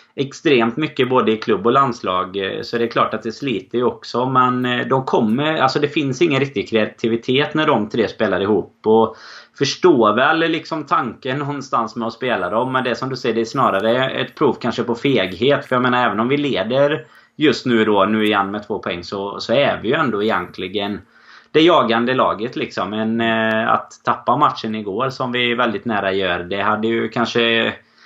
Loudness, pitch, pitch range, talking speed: -18 LUFS, 120 Hz, 110-130 Hz, 200 wpm